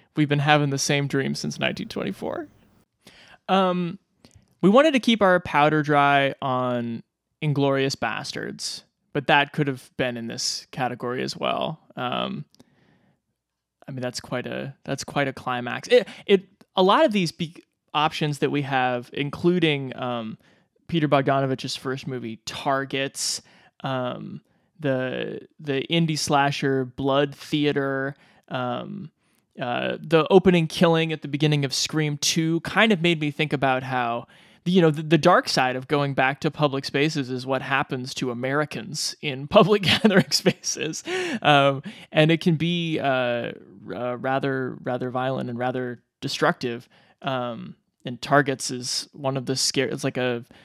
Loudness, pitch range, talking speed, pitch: -23 LUFS, 130-160 Hz, 150 wpm, 140 Hz